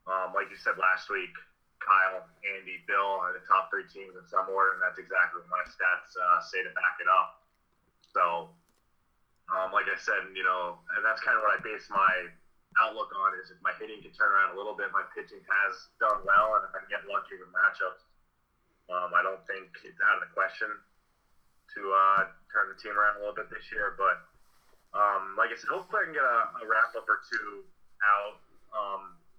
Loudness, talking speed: -29 LUFS, 215 wpm